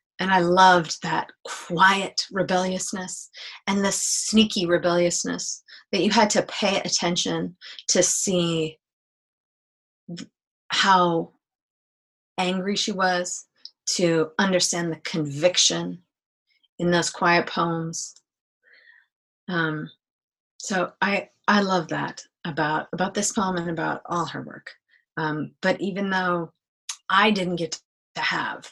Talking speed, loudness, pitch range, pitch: 115 wpm, -23 LUFS, 165-190 Hz, 180 Hz